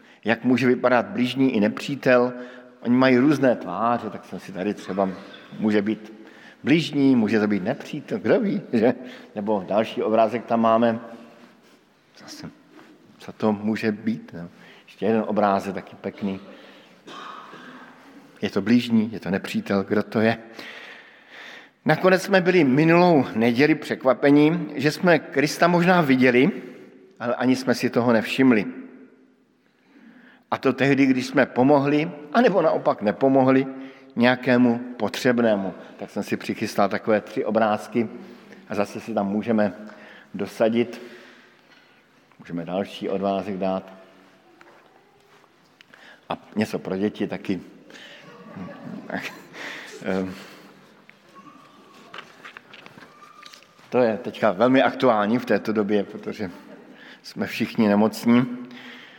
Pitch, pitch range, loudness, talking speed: 120 Hz, 105-135 Hz, -22 LUFS, 115 wpm